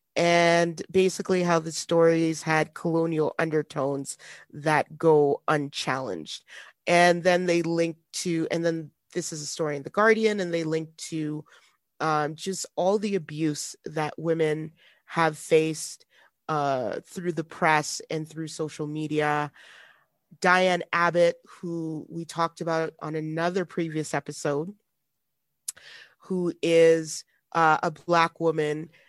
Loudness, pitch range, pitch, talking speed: -26 LUFS, 155-170 Hz, 165 Hz, 130 wpm